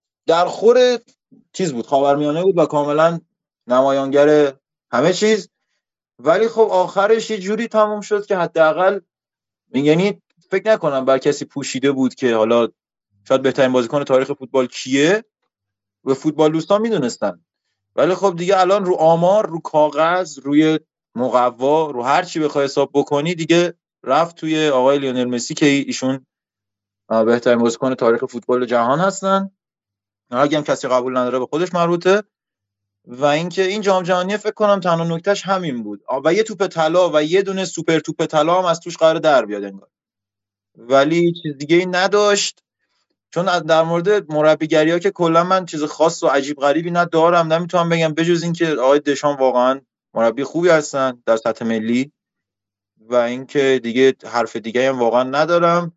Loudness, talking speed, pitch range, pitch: -17 LUFS, 160 wpm, 130-180 Hz, 155 Hz